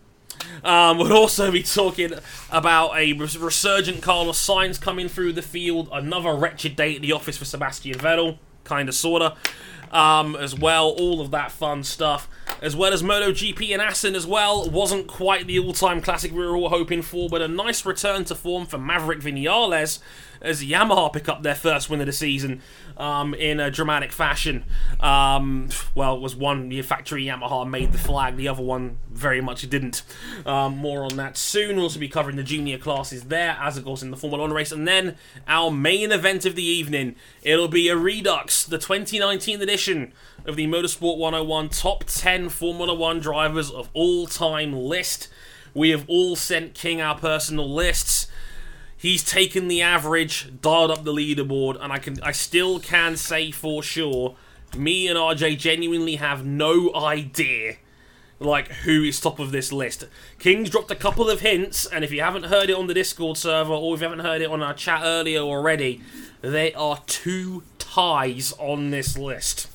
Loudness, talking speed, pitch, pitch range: -22 LUFS, 185 wpm, 160 Hz, 145-175 Hz